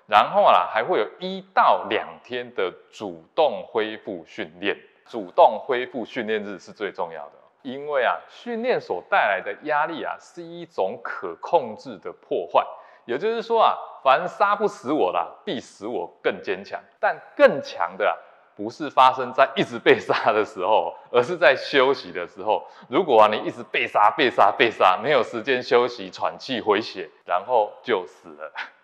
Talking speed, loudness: 245 characters per minute, -22 LUFS